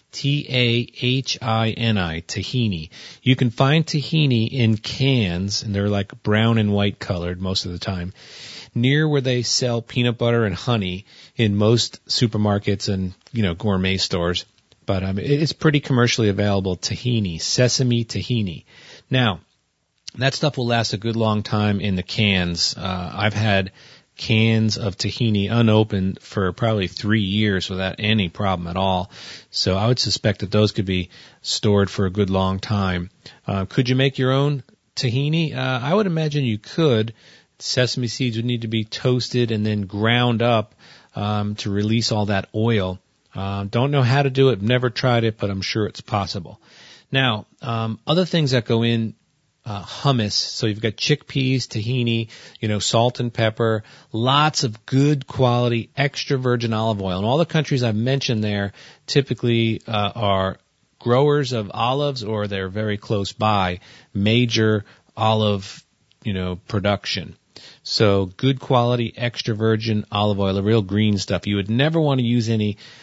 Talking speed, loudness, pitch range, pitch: 165 wpm, -21 LUFS, 100-125 Hz, 110 Hz